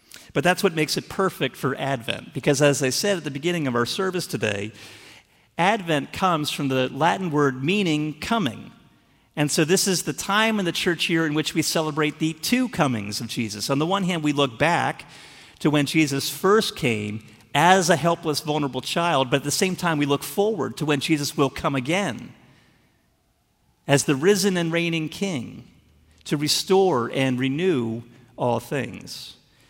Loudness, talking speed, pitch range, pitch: -22 LUFS, 180 wpm, 135-180 Hz, 150 Hz